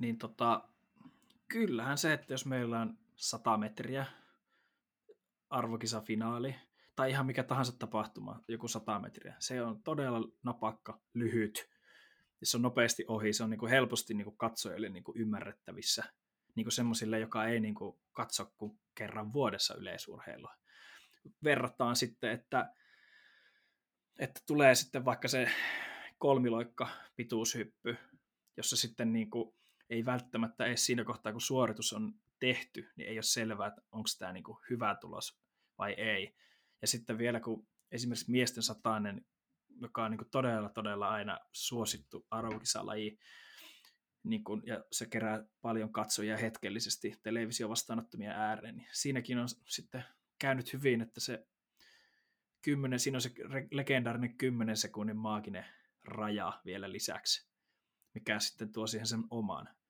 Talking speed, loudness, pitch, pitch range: 130 wpm, -36 LUFS, 115 Hz, 110-135 Hz